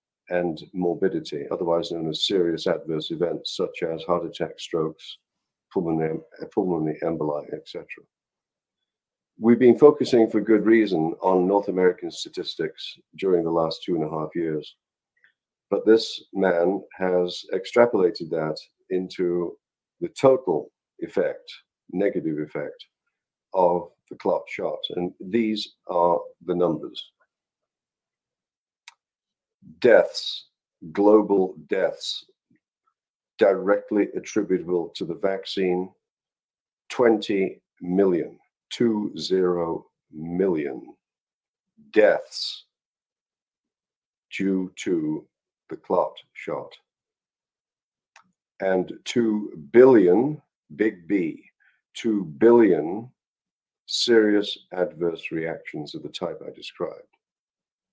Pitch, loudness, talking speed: 105 Hz, -23 LUFS, 95 wpm